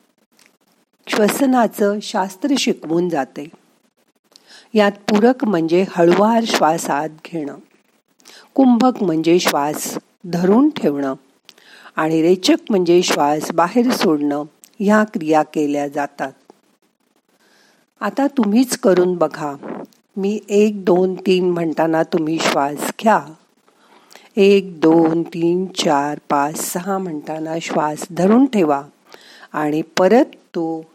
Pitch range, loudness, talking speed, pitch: 160-210 Hz, -17 LUFS, 95 wpm, 180 Hz